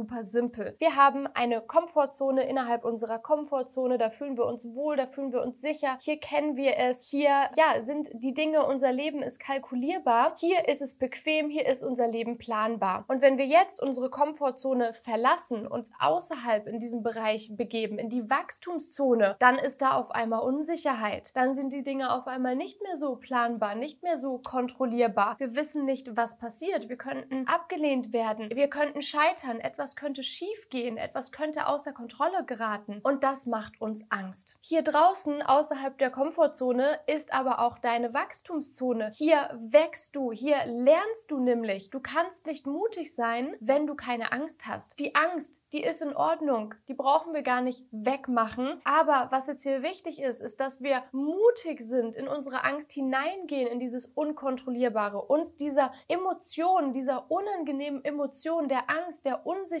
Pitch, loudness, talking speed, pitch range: 270 Hz, -28 LUFS, 170 wpm, 245-300 Hz